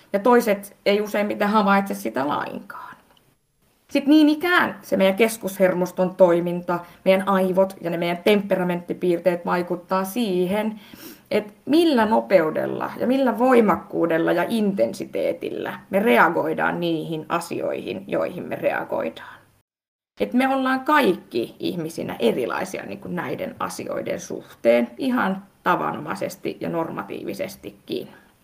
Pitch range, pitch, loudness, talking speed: 175-245 Hz, 195 Hz, -22 LUFS, 110 wpm